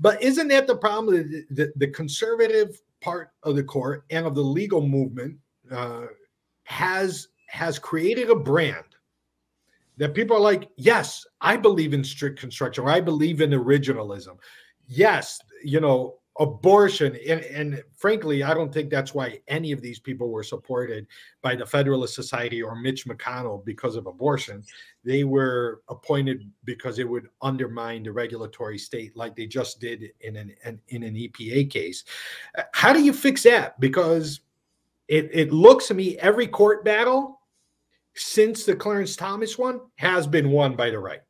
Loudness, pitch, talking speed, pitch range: -22 LUFS, 145 Hz, 165 wpm, 120-185 Hz